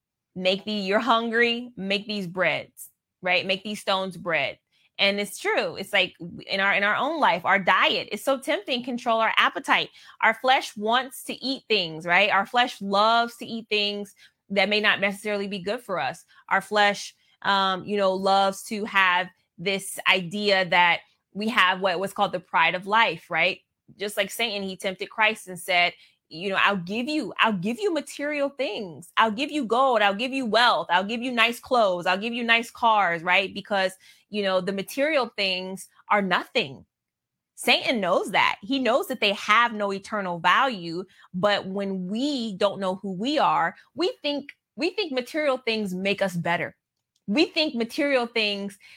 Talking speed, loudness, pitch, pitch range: 185 wpm, -24 LUFS, 205 Hz, 190-240 Hz